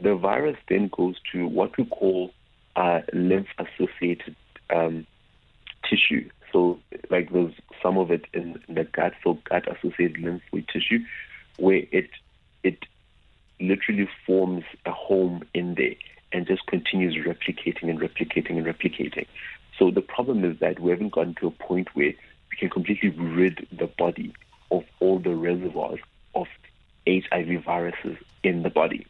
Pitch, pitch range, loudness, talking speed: 90 Hz, 85-95 Hz, -25 LUFS, 150 wpm